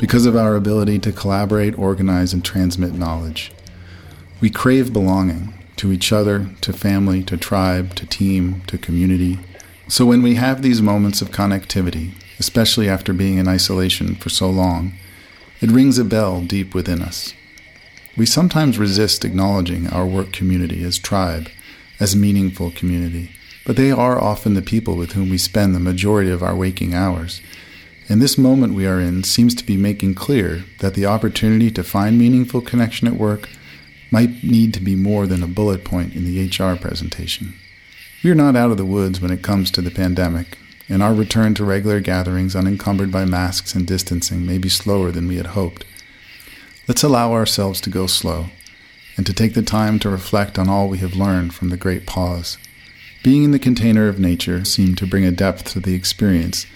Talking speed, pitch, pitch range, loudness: 185 wpm, 95 Hz, 90-105 Hz, -17 LUFS